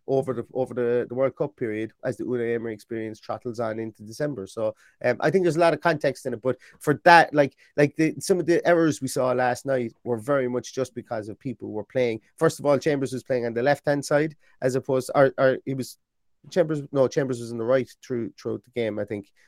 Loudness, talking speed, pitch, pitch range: -25 LUFS, 255 wpm, 130 Hz, 120-145 Hz